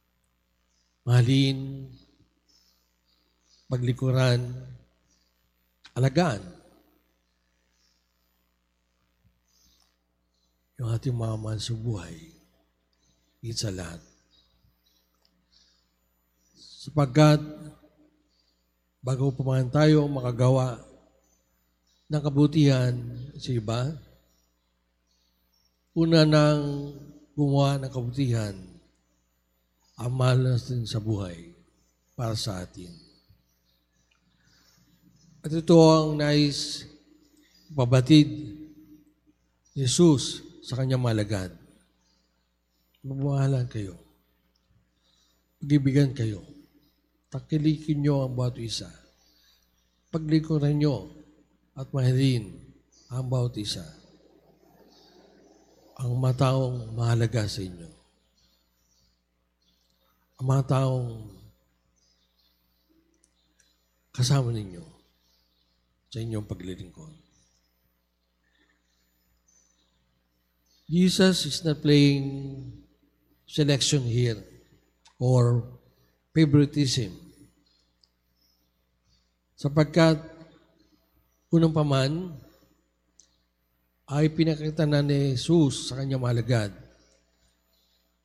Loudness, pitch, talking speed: -25 LUFS, 100 Hz, 65 wpm